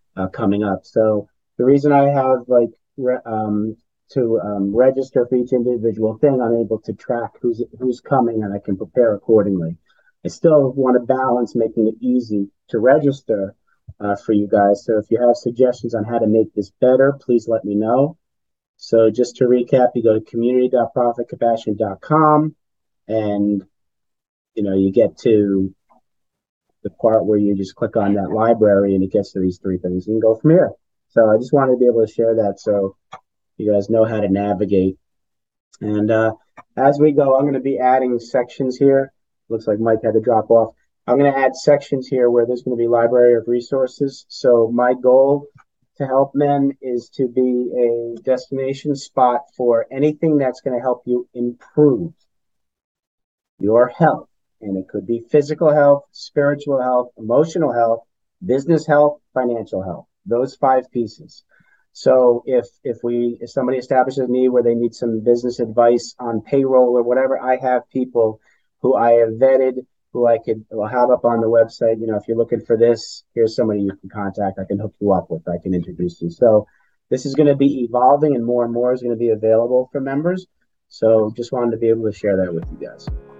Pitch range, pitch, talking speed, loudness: 110-130 Hz, 120 Hz, 195 wpm, -17 LUFS